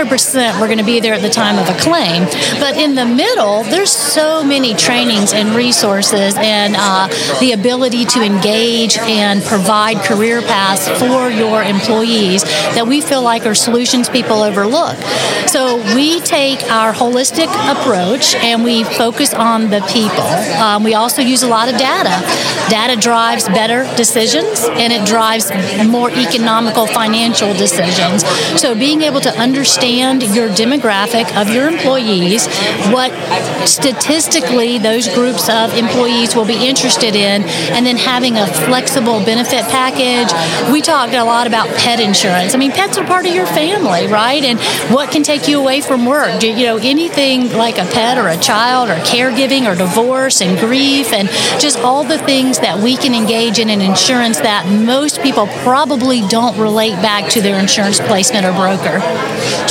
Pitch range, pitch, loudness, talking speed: 215-255 Hz, 235 Hz, -11 LUFS, 170 wpm